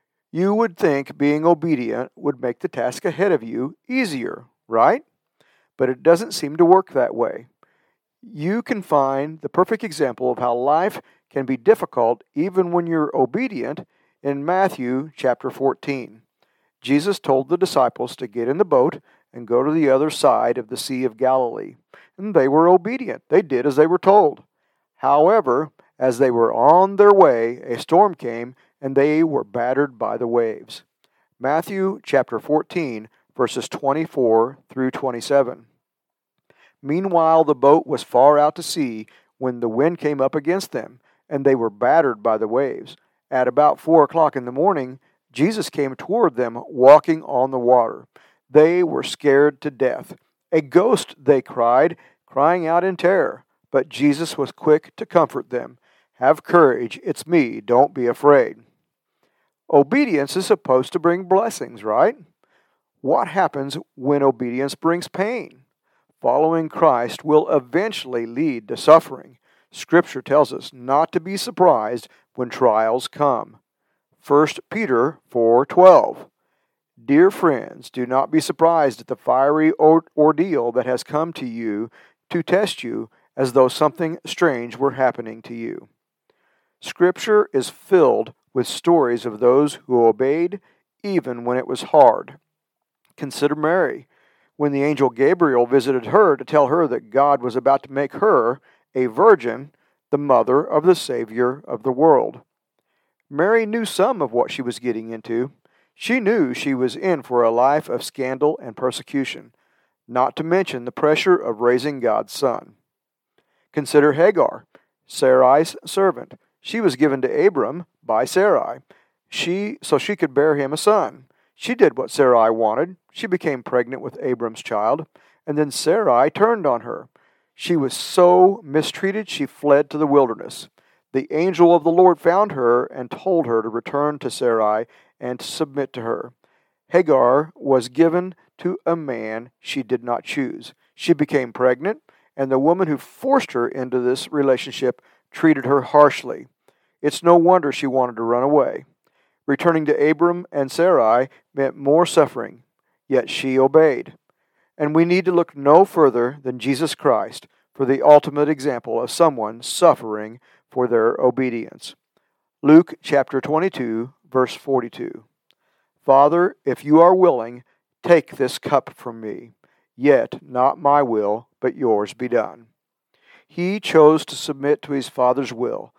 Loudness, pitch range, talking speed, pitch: -18 LUFS, 125-170 Hz, 155 wpm, 145 Hz